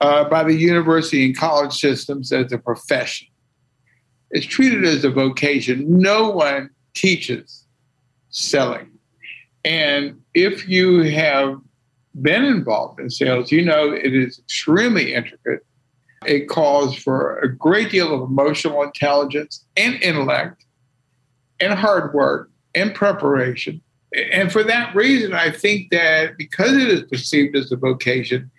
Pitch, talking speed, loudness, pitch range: 145 Hz, 130 wpm, -18 LUFS, 130-170 Hz